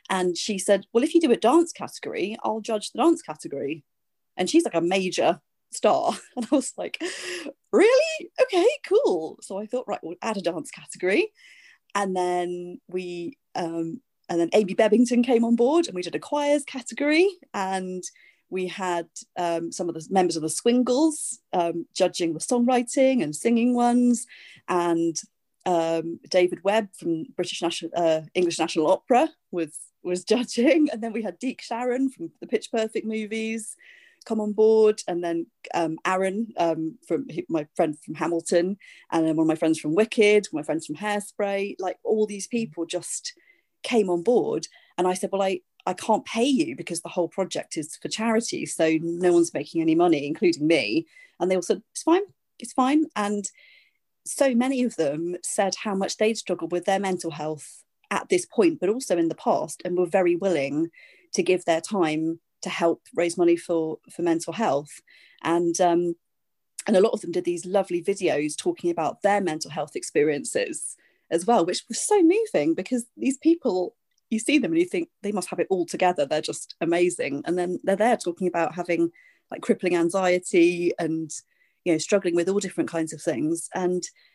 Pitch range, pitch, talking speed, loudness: 170-245 Hz, 195 Hz, 190 wpm, -25 LUFS